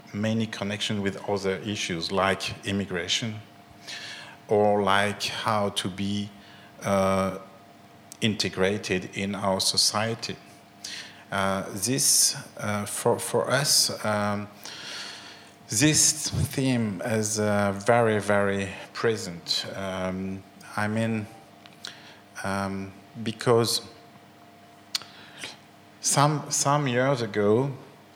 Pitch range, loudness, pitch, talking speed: 100-115 Hz, -25 LUFS, 100 Hz, 85 wpm